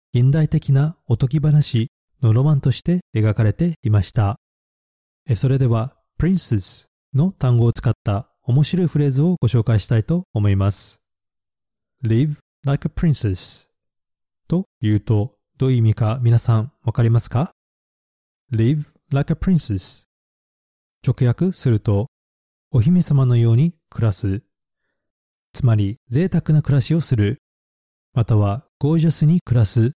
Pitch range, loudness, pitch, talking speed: 110-150 Hz, -19 LUFS, 120 Hz, 300 characters per minute